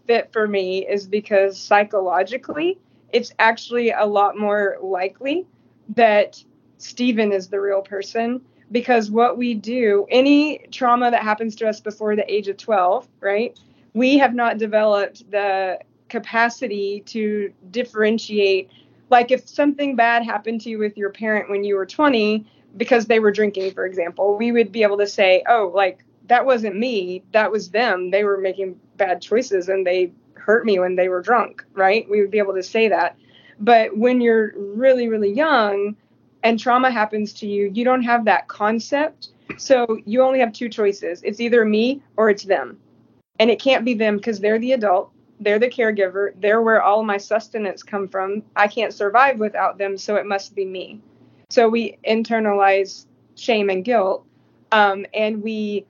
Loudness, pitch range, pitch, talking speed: -19 LUFS, 200-235 Hz, 215 Hz, 175 wpm